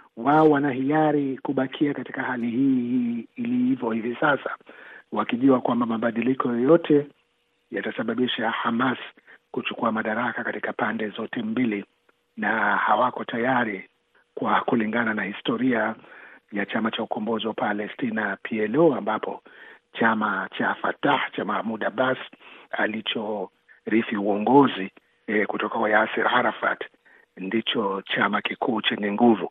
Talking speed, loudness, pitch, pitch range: 115 wpm, -24 LUFS, 130 Hz, 115-145 Hz